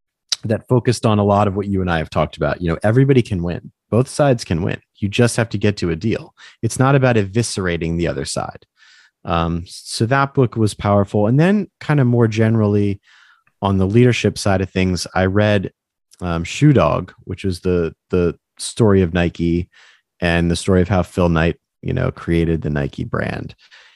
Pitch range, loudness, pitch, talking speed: 85-115 Hz, -18 LUFS, 100 Hz, 200 wpm